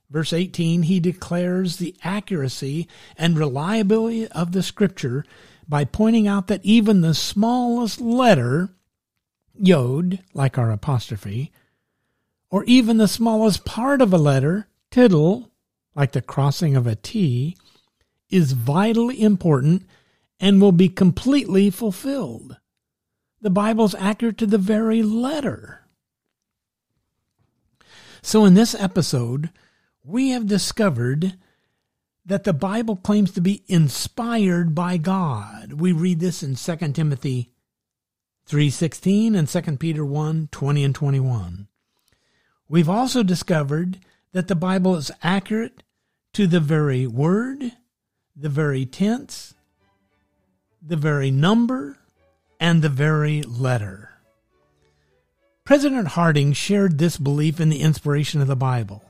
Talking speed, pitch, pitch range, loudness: 115 wpm, 170 Hz, 140-205 Hz, -20 LUFS